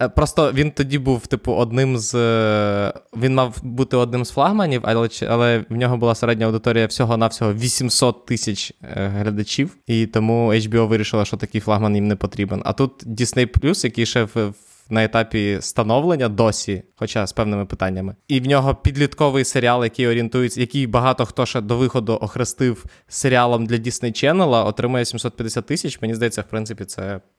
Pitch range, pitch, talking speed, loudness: 110-125 Hz, 115 Hz, 165 wpm, -19 LUFS